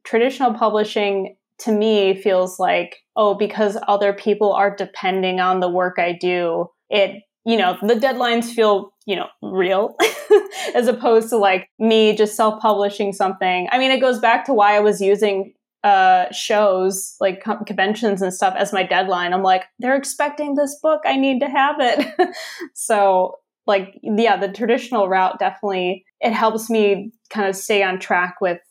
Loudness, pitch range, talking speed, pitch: -18 LUFS, 190-235 Hz, 170 wpm, 205 Hz